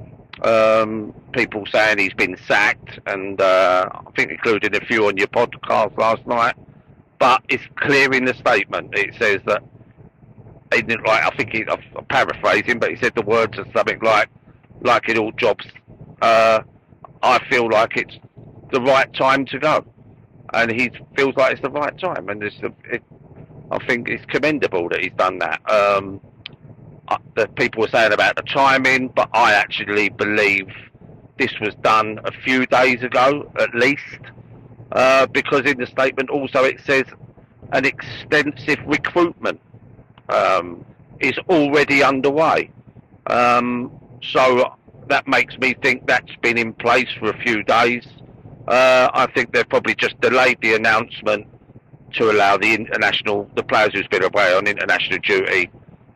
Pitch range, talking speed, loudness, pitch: 110-135 Hz, 155 wpm, -17 LUFS, 125 Hz